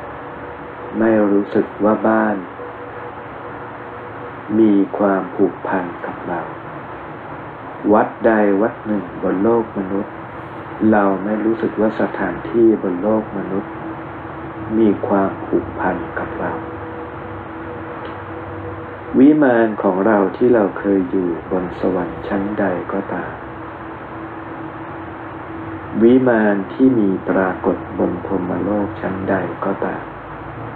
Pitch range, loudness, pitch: 95-110 Hz, -18 LUFS, 105 Hz